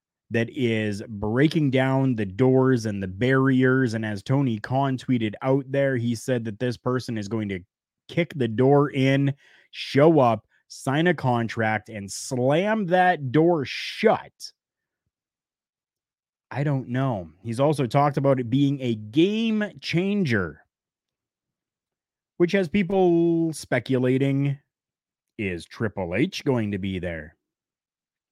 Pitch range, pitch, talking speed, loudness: 115-145 Hz, 130 Hz, 130 wpm, -23 LUFS